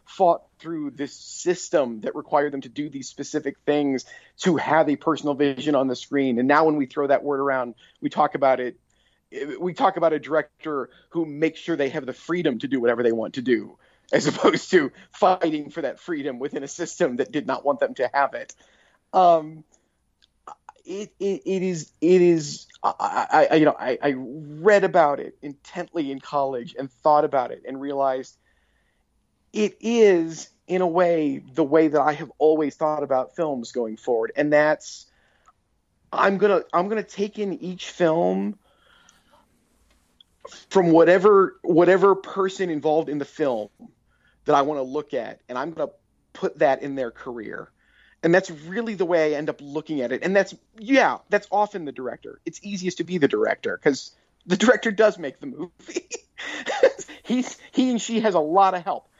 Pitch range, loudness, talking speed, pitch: 140-185 Hz, -22 LUFS, 190 wpm, 155 Hz